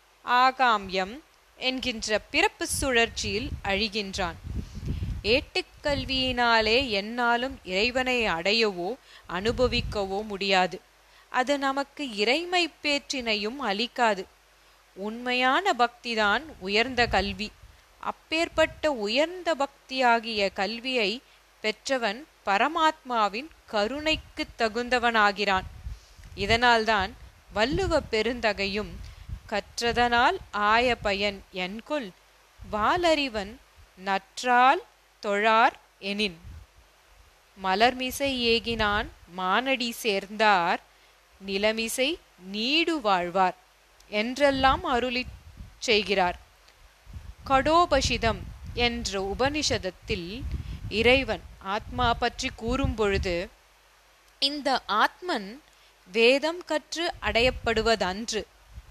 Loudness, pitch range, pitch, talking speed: -26 LUFS, 205-265 Hz, 230 Hz, 60 wpm